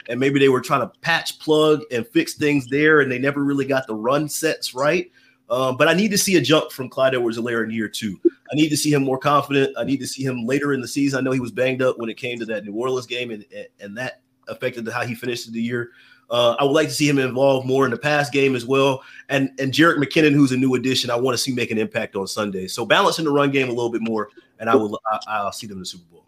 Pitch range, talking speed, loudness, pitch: 120-145 Hz, 290 wpm, -20 LUFS, 130 Hz